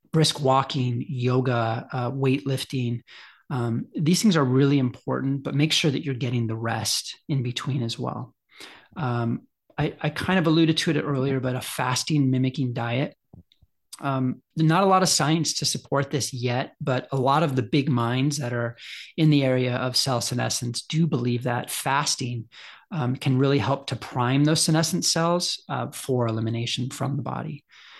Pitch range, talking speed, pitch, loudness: 125-150 Hz, 175 wpm, 135 Hz, -24 LUFS